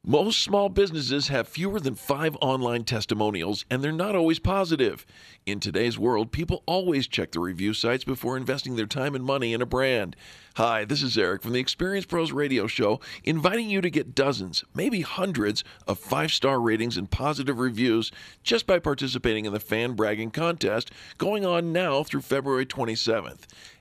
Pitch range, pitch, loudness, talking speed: 115-160 Hz, 130 Hz, -26 LUFS, 175 wpm